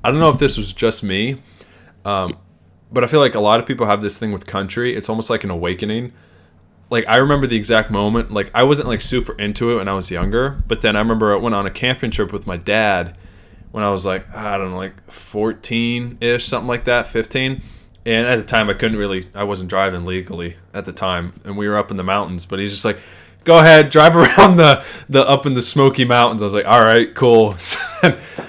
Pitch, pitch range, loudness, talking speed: 105 Hz, 95-120 Hz, -15 LUFS, 235 wpm